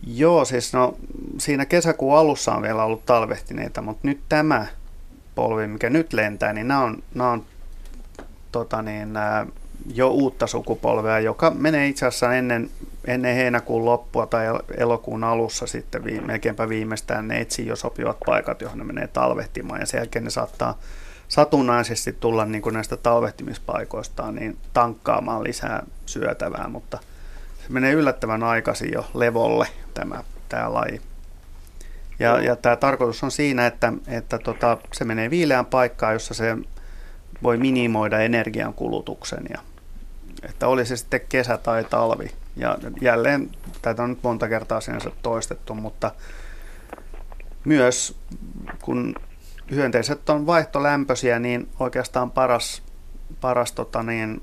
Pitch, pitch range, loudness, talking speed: 120 Hz, 110-130 Hz, -22 LUFS, 135 wpm